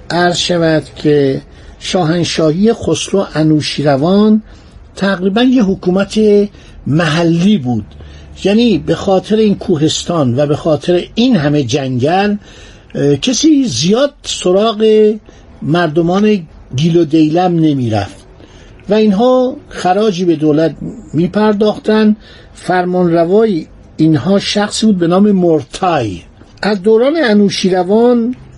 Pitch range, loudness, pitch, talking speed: 150-210 Hz, -12 LUFS, 180 Hz, 105 wpm